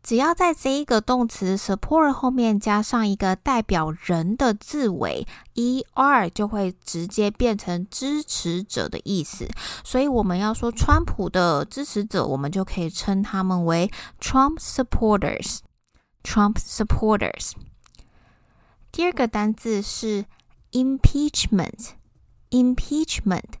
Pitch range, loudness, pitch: 190-255 Hz, -23 LUFS, 215 Hz